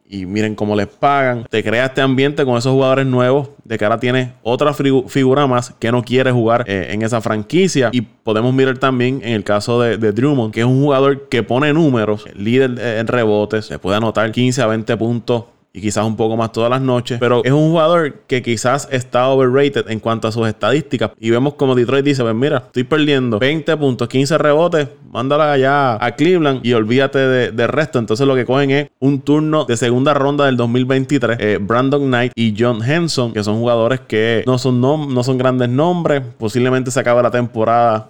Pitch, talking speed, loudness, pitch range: 125 Hz, 210 wpm, -15 LUFS, 115-135 Hz